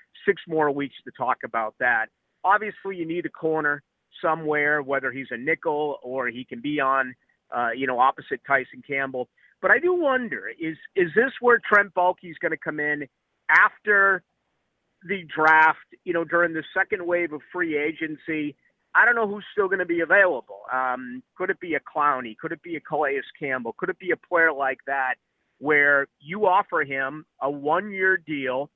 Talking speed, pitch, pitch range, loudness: 190 wpm, 155 Hz, 140-190 Hz, -23 LUFS